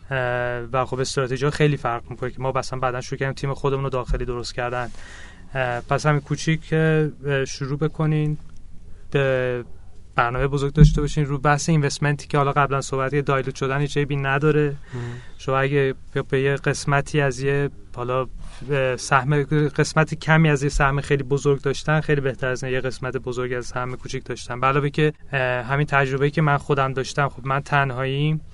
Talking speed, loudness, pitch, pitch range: 165 wpm, -22 LUFS, 135 Hz, 125-145 Hz